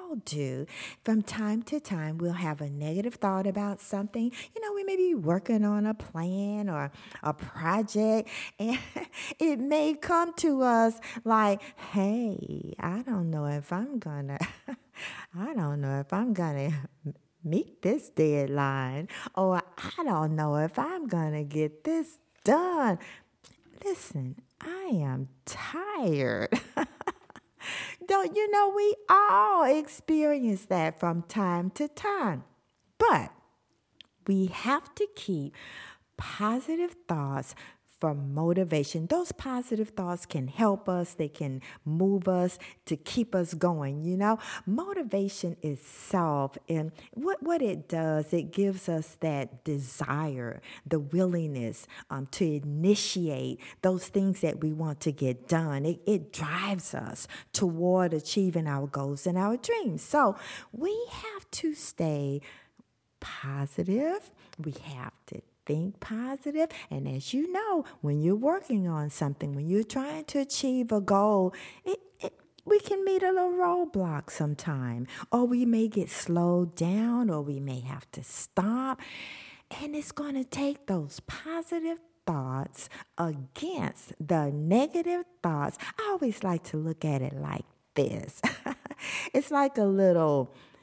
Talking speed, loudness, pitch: 135 wpm, -30 LUFS, 190 Hz